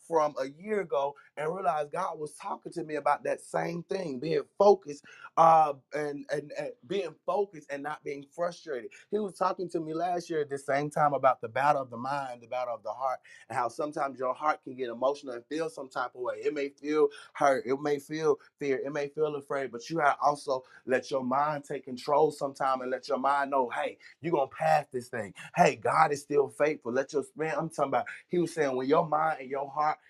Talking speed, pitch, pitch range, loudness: 235 wpm, 145 Hz, 140-160 Hz, -30 LUFS